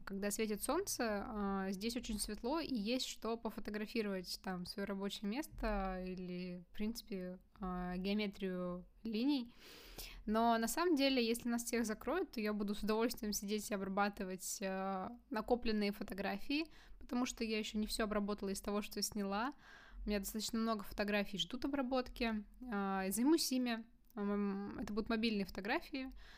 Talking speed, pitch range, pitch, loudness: 140 wpm, 200-235 Hz, 215 Hz, -40 LUFS